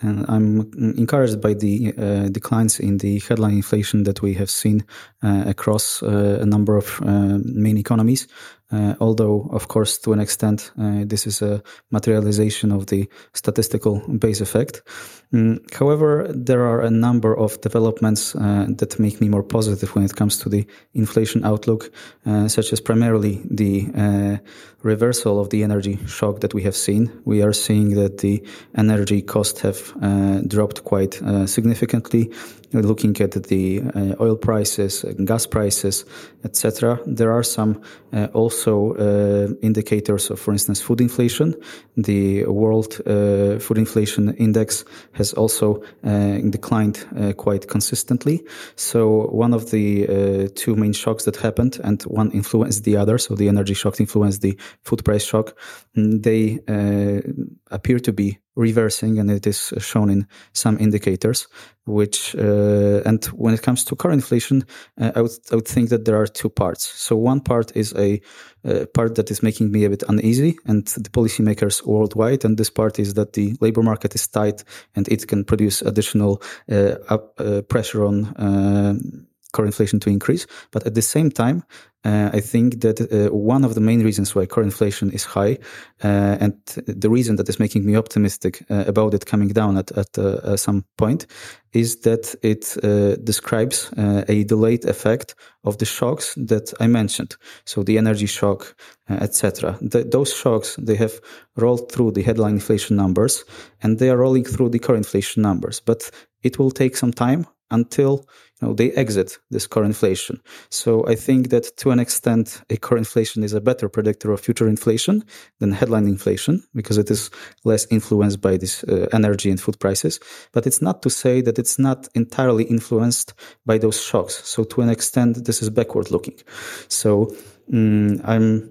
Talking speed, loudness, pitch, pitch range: 175 wpm, -19 LUFS, 110 Hz, 105-115 Hz